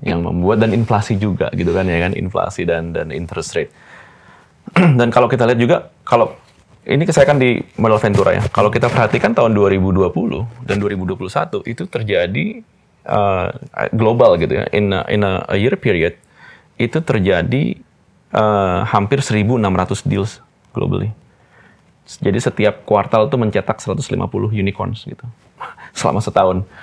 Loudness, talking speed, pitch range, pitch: -16 LUFS, 140 wpm, 100-125 Hz, 110 Hz